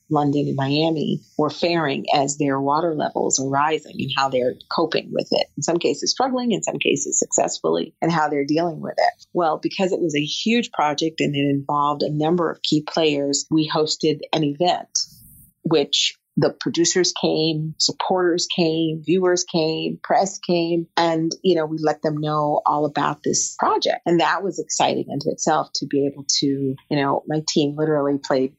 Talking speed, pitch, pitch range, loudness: 185 wpm, 155 Hz, 145-170 Hz, -21 LUFS